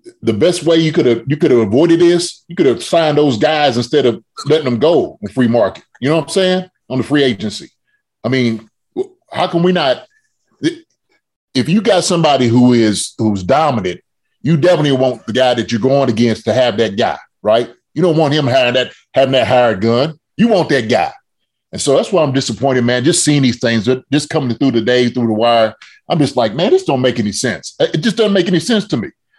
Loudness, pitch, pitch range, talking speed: -14 LUFS, 135 Hz, 120-175 Hz, 230 wpm